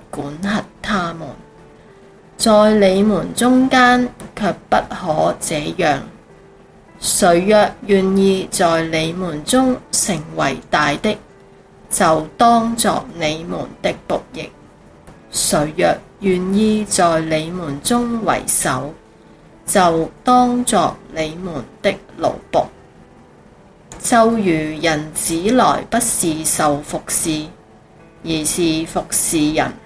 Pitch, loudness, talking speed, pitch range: 190 Hz, -15 LUFS, 135 characters per minute, 160-225 Hz